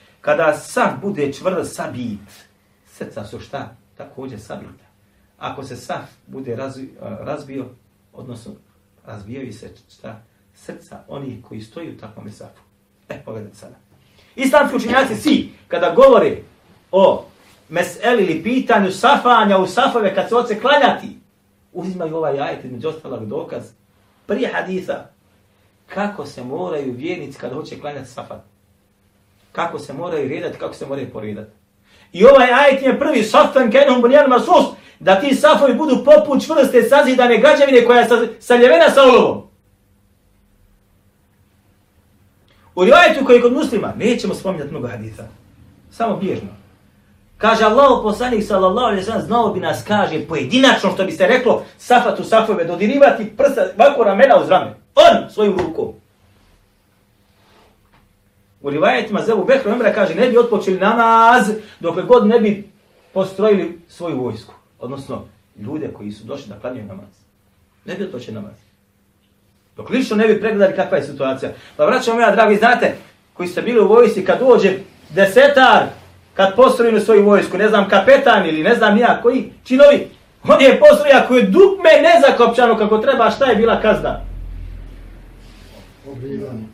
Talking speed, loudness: 145 wpm, -13 LUFS